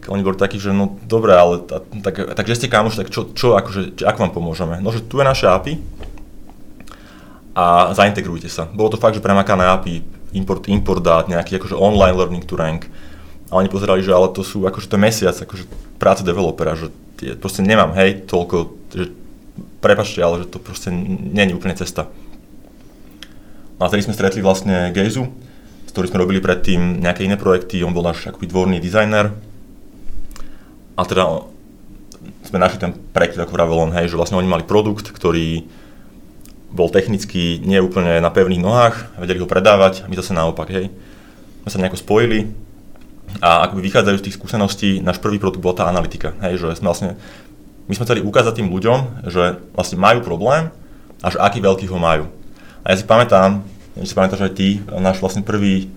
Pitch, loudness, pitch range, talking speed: 95 Hz, -16 LUFS, 90-100 Hz, 185 wpm